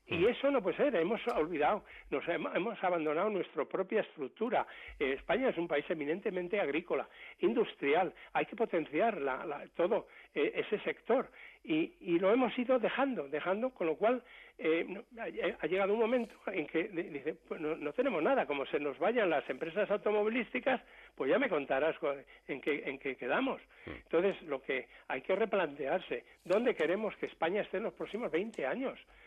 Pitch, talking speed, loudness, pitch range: 215 Hz, 170 wpm, -34 LUFS, 170-260 Hz